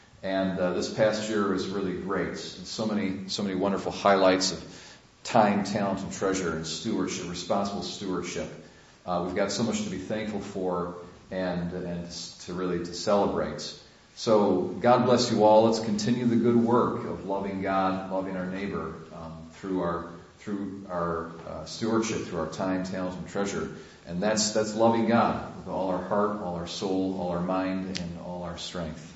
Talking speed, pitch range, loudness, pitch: 180 wpm, 90-105 Hz, -28 LUFS, 95 Hz